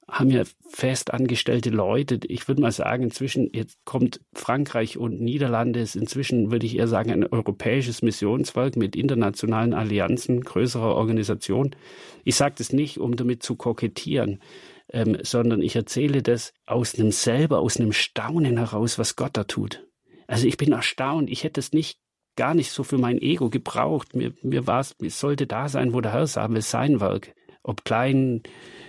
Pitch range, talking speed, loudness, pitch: 115-135 Hz, 175 wpm, -24 LUFS, 120 Hz